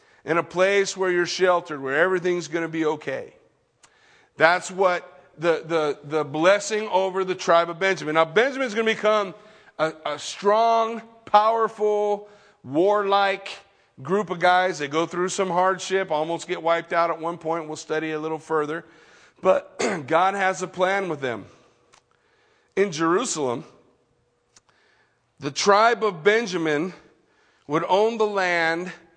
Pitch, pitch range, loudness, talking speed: 180 Hz, 165-200 Hz, -23 LUFS, 140 wpm